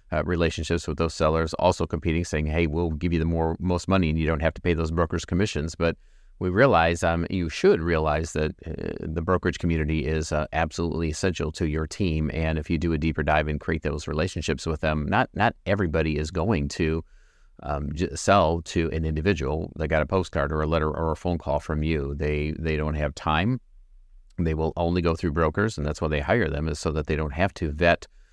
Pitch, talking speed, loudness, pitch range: 80 Hz, 225 wpm, -25 LUFS, 75-85 Hz